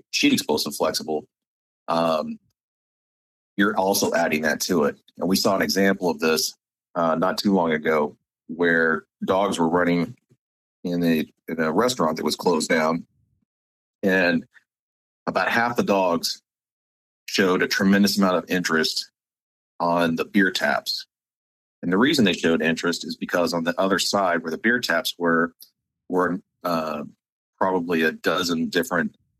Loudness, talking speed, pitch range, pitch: -22 LUFS, 150 wpm, 80-95 Hz, 85 Hz